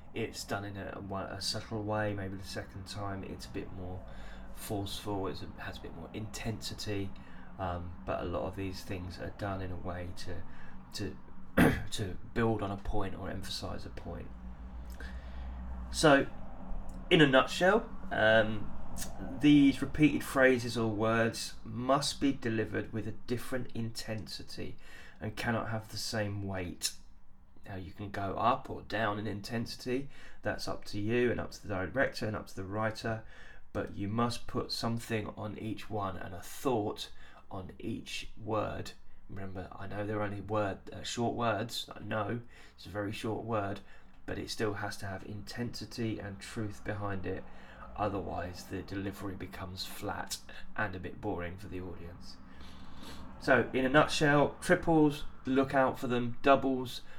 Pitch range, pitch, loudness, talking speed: 95-115 Hz, 100 Hz, -34 LUFS, 165 wpm